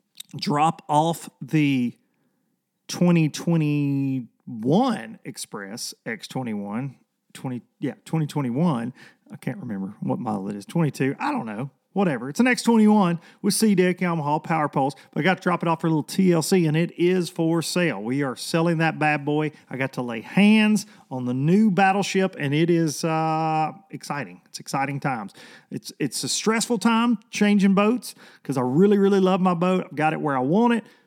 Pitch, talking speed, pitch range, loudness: 165 Hz, 175 wpm, 145-195 Hz, -23 LUFS